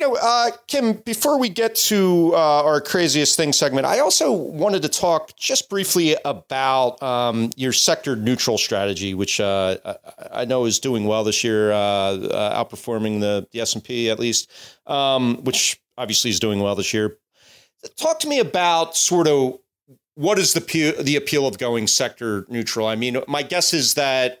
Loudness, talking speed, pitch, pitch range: -19 LUFS, 185 wpm, 130 Hz, 115-170 Hz